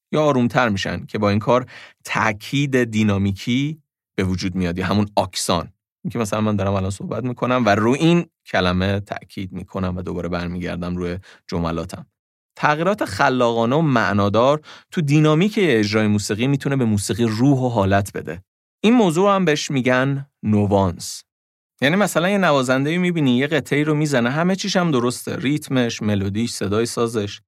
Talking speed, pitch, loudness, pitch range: 155 wpm, 115 Hz, -19 LUFS, 100-140 Hz